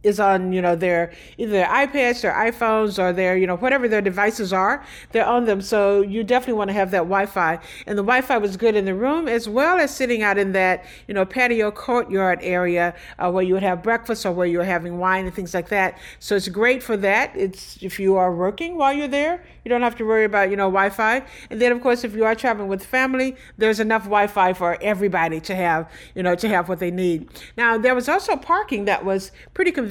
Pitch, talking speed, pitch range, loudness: 205 Hz, 240 wpm, 185-240 Hz, -20 LUFS